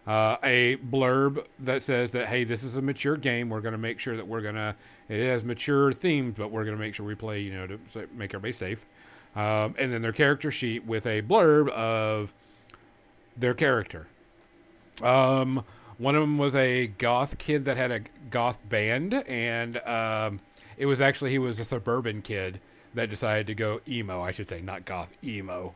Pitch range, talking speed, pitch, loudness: 110-130 Hz, 200 wpm, 120 Hz, -27 LUFS